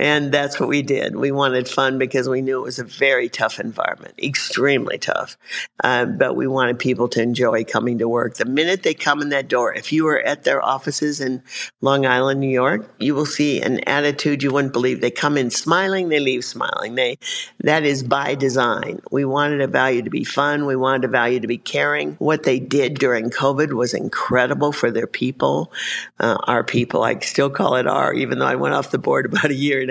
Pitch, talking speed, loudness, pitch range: 135 Hz, 220 wpm, -19 LUFS, 125-145 Hz